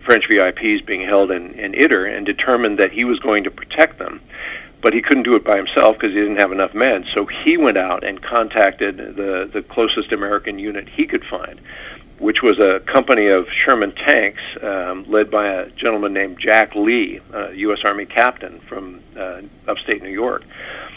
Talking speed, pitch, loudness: 195 wpm, 110 Hz, -16 LUFS